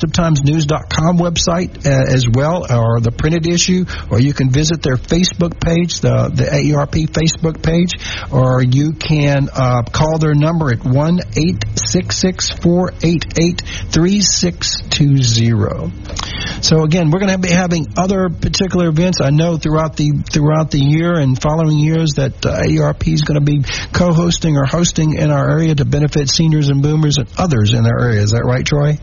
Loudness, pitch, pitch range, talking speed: -14 LUFS, 155 Hz, 135-170 Hz, 185 wpm